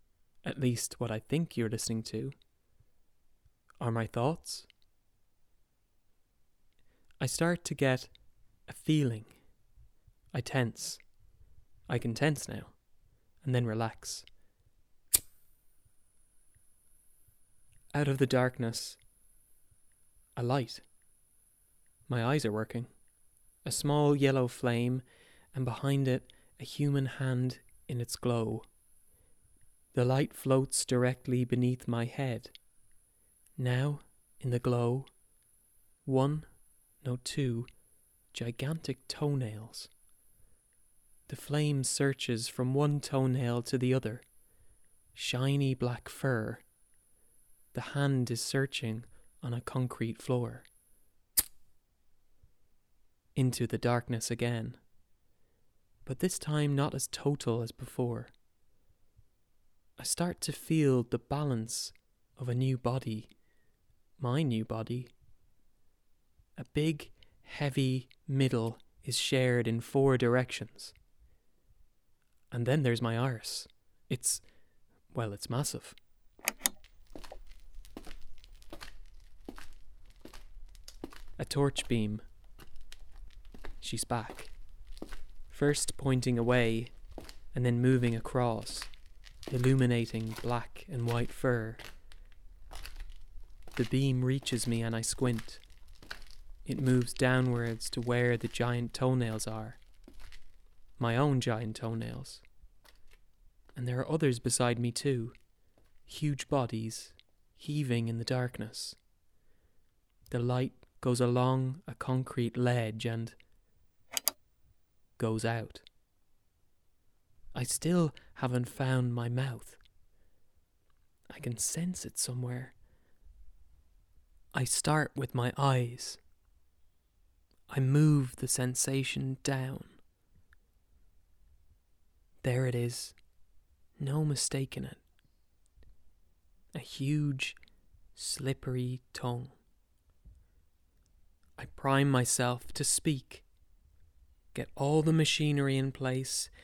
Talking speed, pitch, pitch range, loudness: 95 wpm, 120 Hz, 95-130 Hz, -33 LUFS